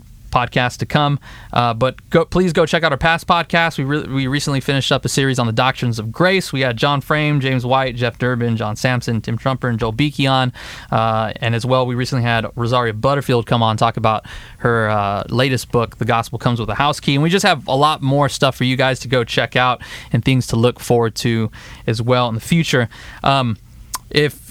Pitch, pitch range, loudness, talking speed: 125 Hz, 115-140 Hz, -17 LUFS, 235 wpm